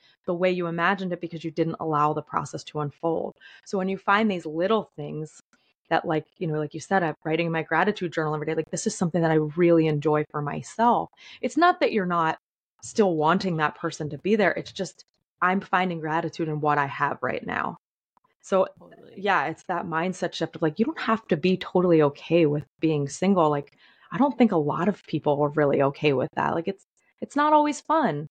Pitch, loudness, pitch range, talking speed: 165 Hz, -25 LUFS, 155-190 Hz, 225 wpm